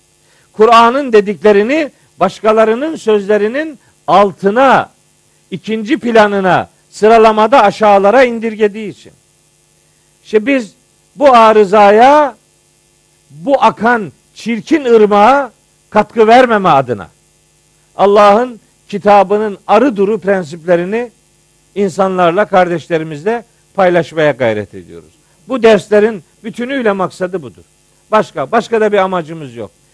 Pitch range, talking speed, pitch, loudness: 185-230 Hz, 85 wpm, 210 Hz, -10 LUFS